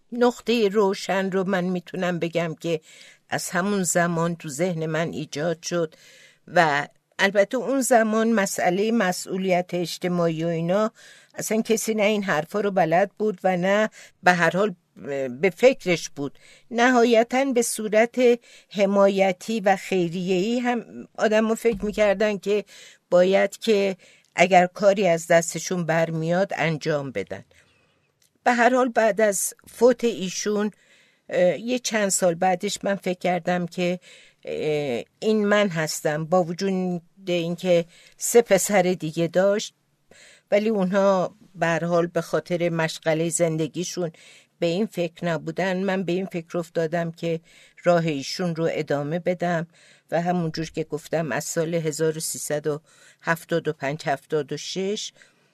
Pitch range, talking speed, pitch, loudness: 170-210 Hz, 125 wpm, 180 Hz, -23 LUFS